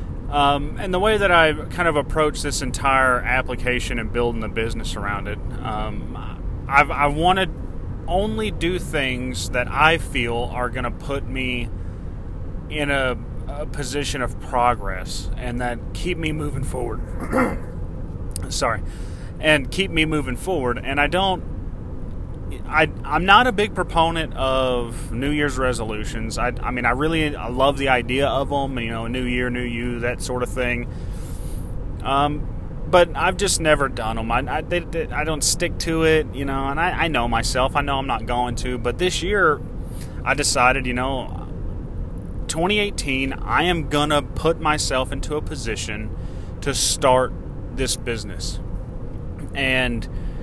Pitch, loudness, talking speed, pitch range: 125 Hz, -22 LUFS, 160 wpm, 110-145 Hz